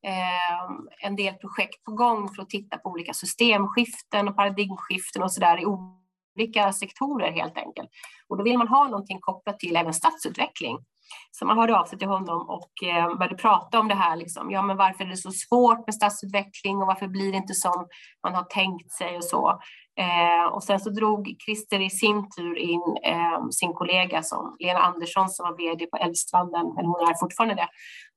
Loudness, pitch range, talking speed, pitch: -25 LUFS, 180-205 Hz, 190 wpm, 190 Hz